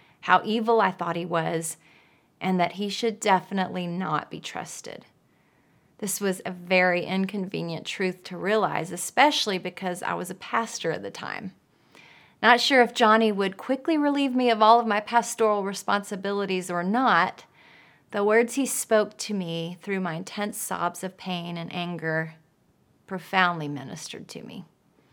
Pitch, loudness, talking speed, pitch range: 190 Hz, -25 LUFS, 155 wpm, 175-220 Hz